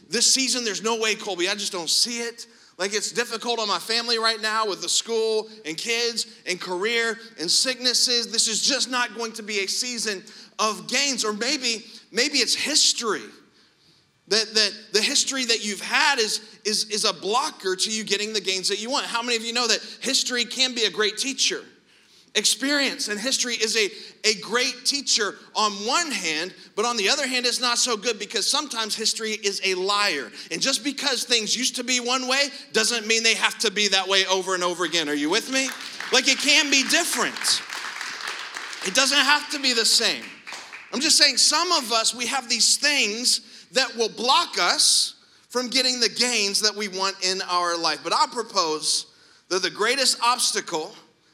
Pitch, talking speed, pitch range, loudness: 225 Hz, 200 wpm, 210-255 Hz, -21 LUFS